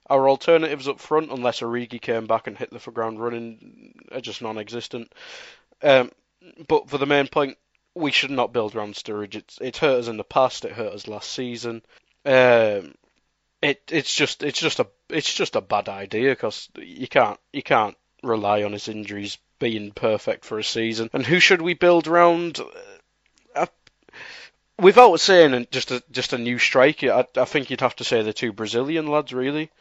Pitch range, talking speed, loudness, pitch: 115-155 Hz, 185 wpm, -21 LUFS, 125 Hz